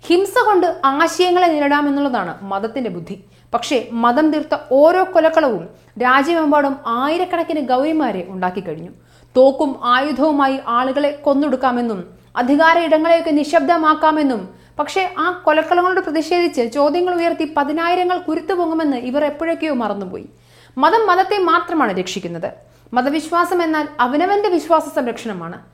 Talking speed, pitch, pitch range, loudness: 100 wpm, 300 Hz, 255-335 Hz, -16 LUFS